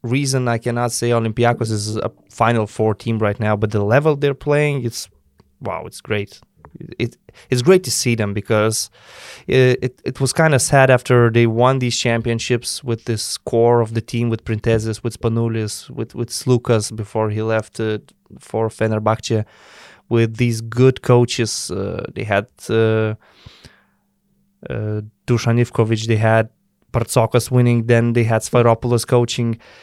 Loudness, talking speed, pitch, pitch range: -18 LUFS, 155 wpm, 115 Hz, 110-125 Hz